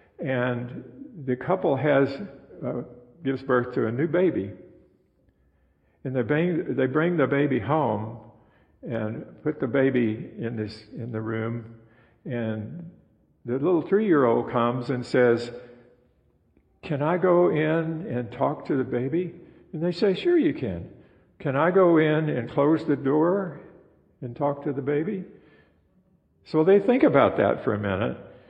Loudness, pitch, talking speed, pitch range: -25 LUFS, 135 Hz, 150 wpm, 120-165 Hz